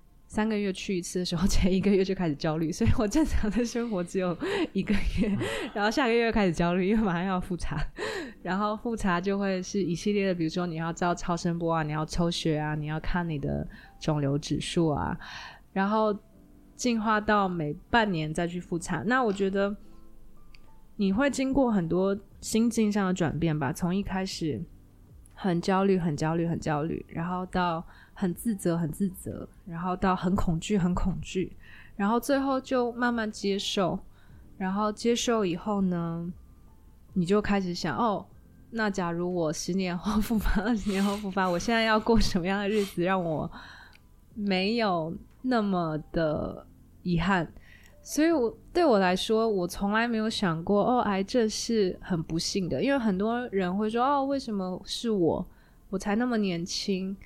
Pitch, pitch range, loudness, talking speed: 190 Hz, 170-215 Hz, -28 LUFS, 255 characters per minute